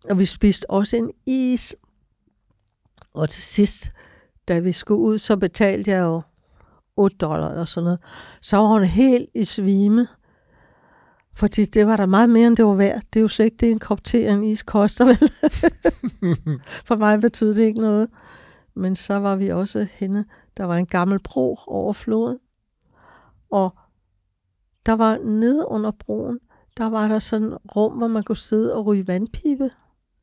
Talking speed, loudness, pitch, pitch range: 175 wpm, -20 LUFS, 210 Hz, 185-225 Hz